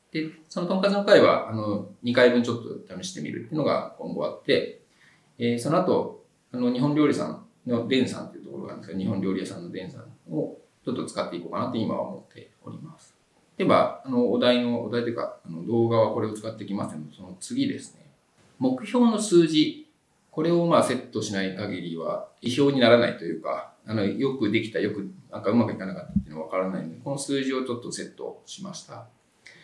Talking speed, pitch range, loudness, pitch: 440 characters per minute, 110-170 Hz, -25 LUFS, 125 Hz